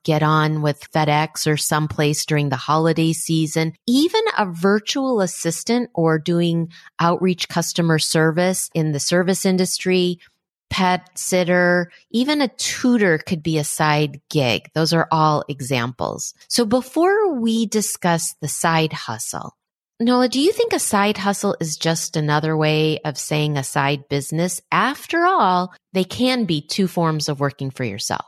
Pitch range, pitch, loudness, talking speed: 150-195 Hz, 165 Hz, -19 LUFS, 150 wpm